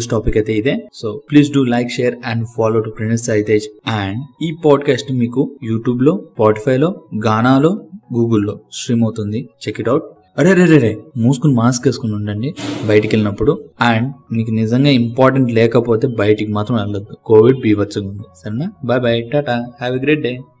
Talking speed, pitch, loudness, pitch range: 165 wpm, 120 Hz, -15 LUFS, 110-135 Hz